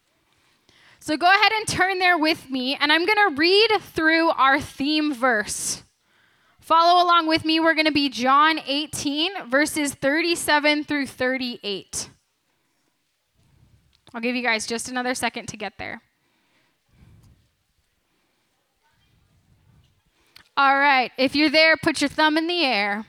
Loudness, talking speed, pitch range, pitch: -20 LUFS, 130 wpm, 260-325 Hz, 300 Hz